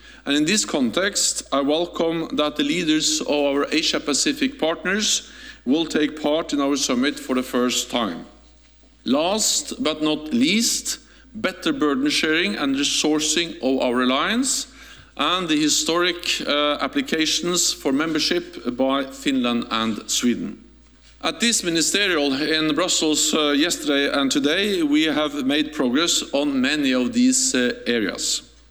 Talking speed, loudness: 140 wpm, -20 LUFS